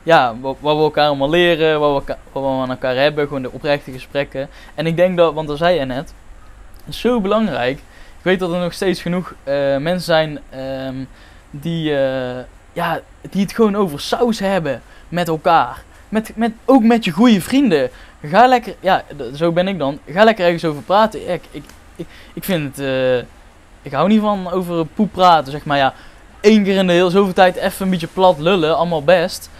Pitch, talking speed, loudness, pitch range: 165 Hz, 205 wpm, -16 LUFS, 135-190 Hz